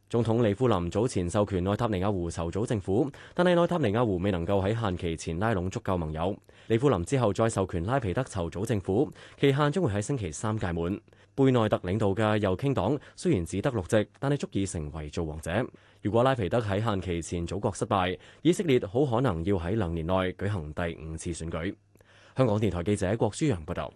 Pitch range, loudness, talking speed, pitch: 90-120 Hz, -28 LUFS, 325 characters per minute, 100 Hz